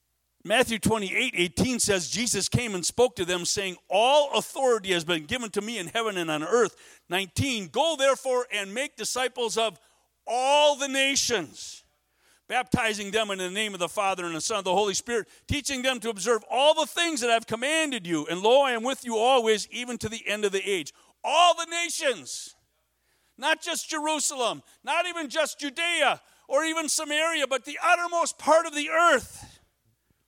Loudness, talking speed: -25 LUFS, 185 wpm